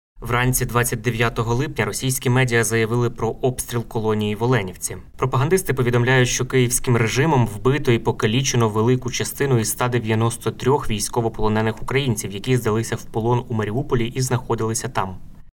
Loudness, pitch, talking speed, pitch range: -21 LUFS, 120 Hz, 130 wpm, 110-125 Hz